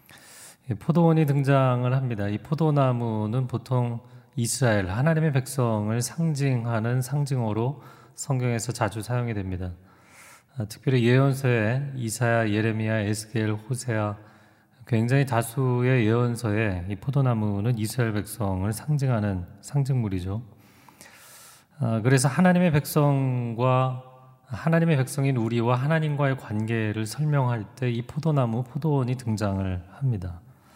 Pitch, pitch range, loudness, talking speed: 120 Hz, 110-135 Hz, -25 LUFS, 290 characters per minute